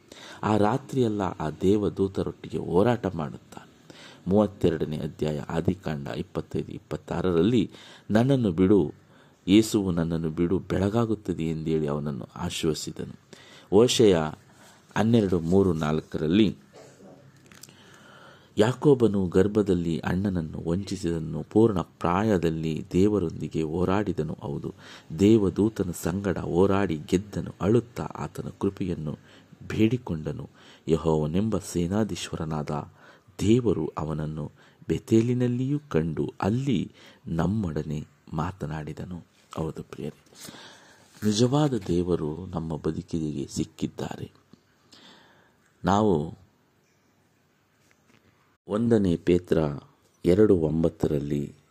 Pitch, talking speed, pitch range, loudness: 90 Hz, 70 wpm, 80-105 Hz, -26 LUFS